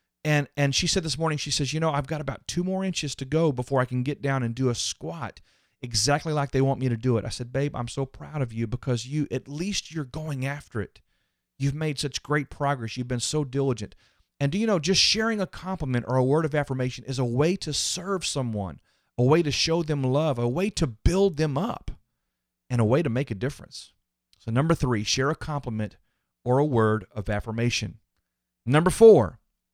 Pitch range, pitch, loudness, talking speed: 120-155 Hz, 135 Hz, -25 LUFS, 225 wpm